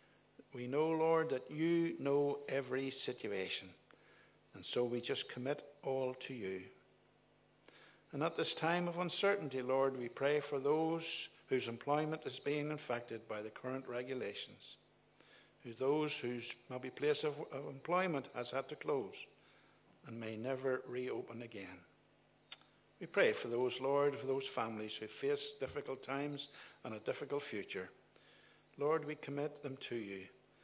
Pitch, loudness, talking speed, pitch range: 135 Hz, -40 LUFS, 145 wpm, 120-150 Hz